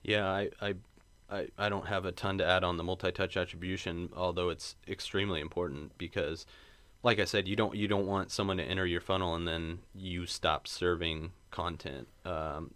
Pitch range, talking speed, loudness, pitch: 85-100 Hz, 190 wpm, -34 LUFS, 90 Hz